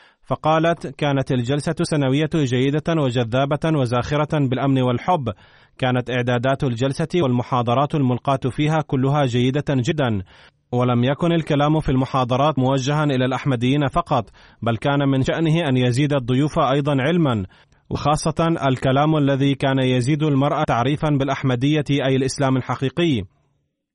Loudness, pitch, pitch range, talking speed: -20 LUFS, 140 Hz, 130-150 Hz, 120 wpm